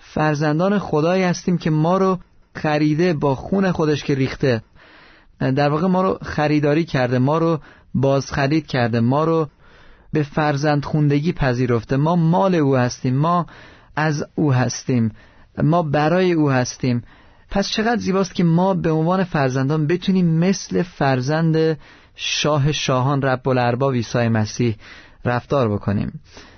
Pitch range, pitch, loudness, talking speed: 130-165 Hz, 150 Hz, -19 LUFS, 135 wpm